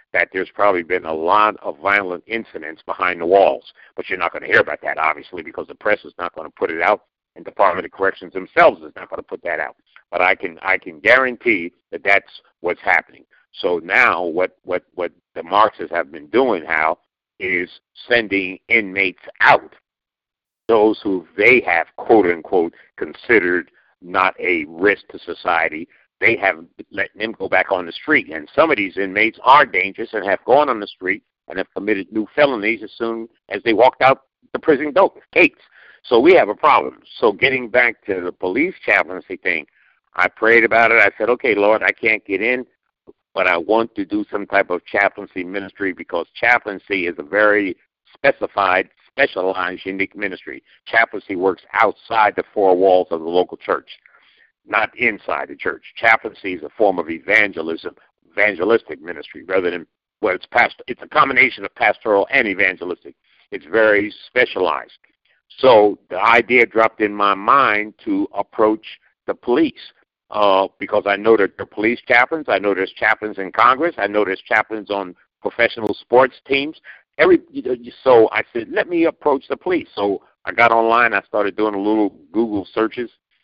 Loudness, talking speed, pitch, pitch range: -17 LUFS, 180 wpm, 105 Hz, 95-120 Hz